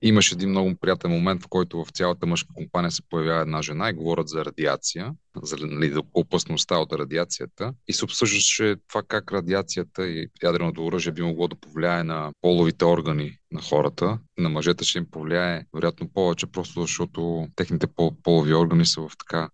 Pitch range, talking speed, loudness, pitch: 80-90 Hz, 180 wpm, -24 LUFS, 85 Hz